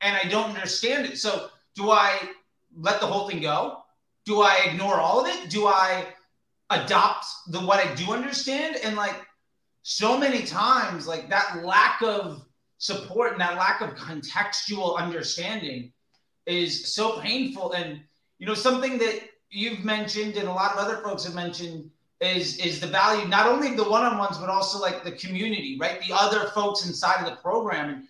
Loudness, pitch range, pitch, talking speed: -24 LUFS, 175-215 Hz, 200 Hz, 180 wpm